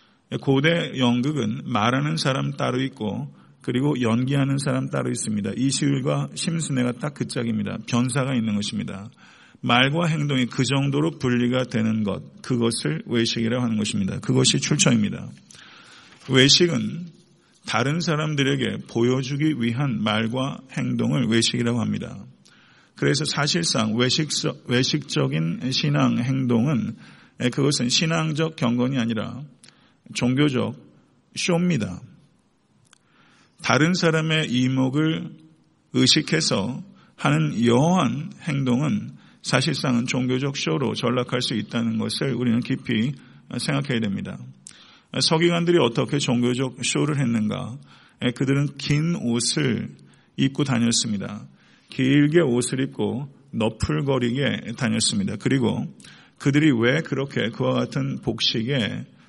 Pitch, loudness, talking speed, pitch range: 130 Hz, -22 LUFS, 265 characters per minute, 120-150 Hz